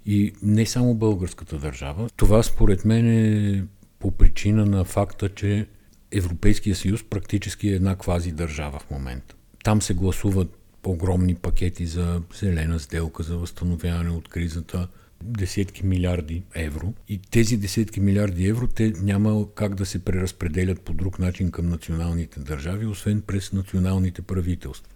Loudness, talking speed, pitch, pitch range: -24 LUFS, 140 wpm, 95 Hz, 85-105 Hz